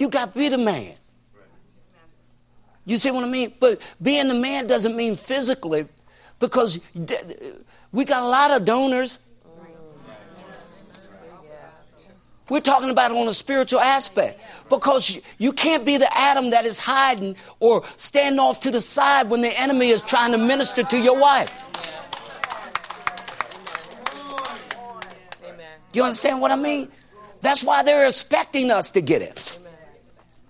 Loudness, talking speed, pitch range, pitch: -19 LUFS, 140 wpm, 215-275 Hz, 255 Hz